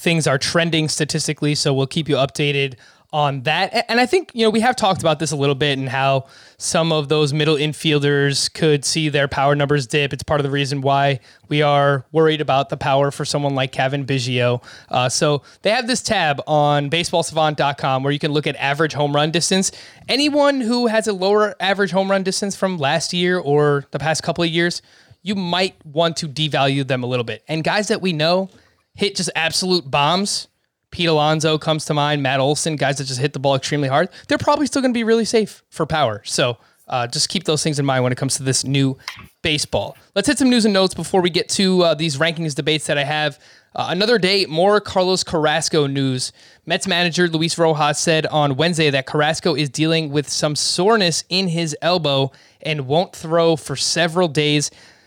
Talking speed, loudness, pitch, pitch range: 210 wpm, -18 LUFS, 155 Hz, 140-175 Hz